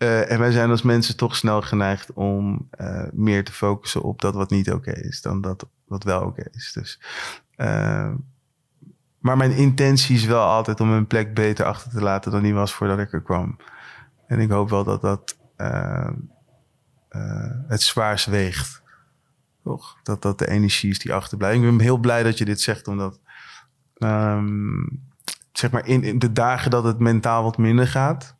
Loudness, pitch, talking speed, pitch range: -21 LUFS, 115 Hz, 190 wpm, 105-130 Hz